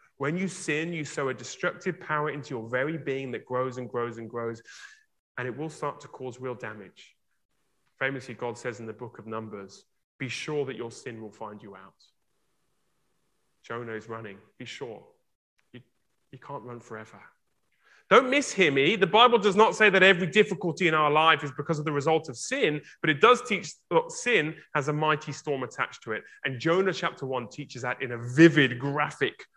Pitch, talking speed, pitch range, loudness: 140 Hz, 195 wpm, 120-160 Hz, -26 LUFS